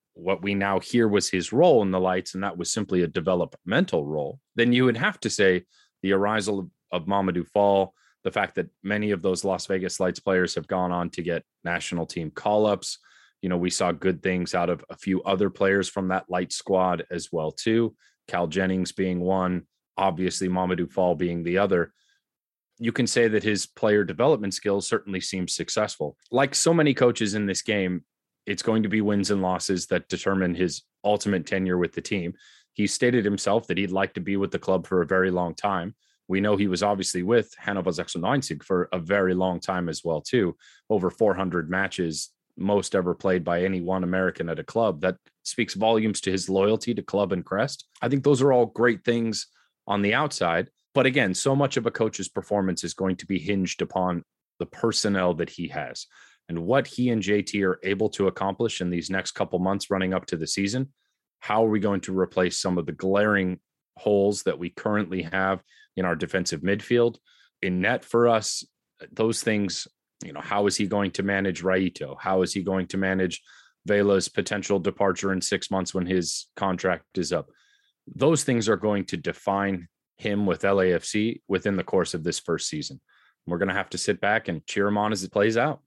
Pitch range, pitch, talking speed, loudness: 90-105 Hz, 95 Hz, 205 wpm, -25 LUFS